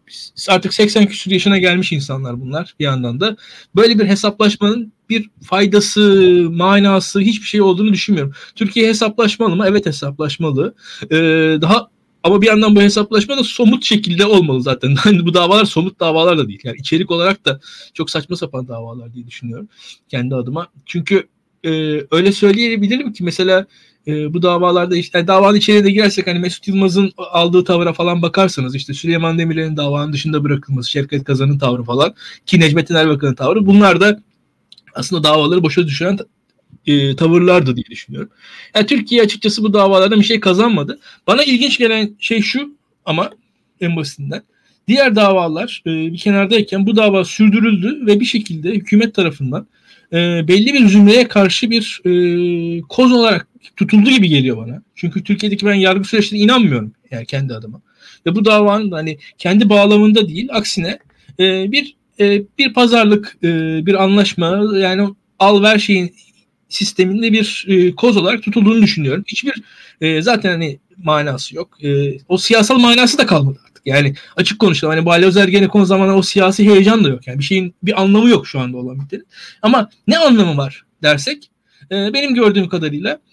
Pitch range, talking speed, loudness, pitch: 160-210 Hz, 160 wpm, -13 LUFS, 190 Hz